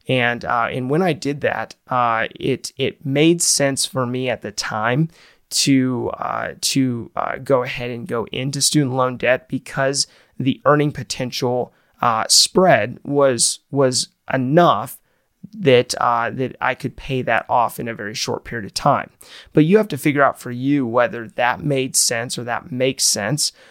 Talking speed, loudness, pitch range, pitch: 175 wpm, -19 LUFS, 125-140 Hz, 130 Hz